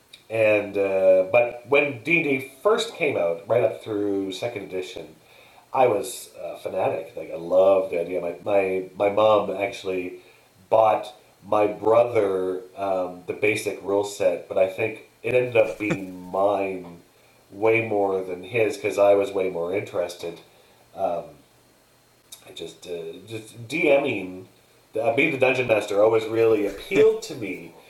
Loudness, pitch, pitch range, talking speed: -23 LUFS, 100 Hz, 95-115 Hz, 155 wpm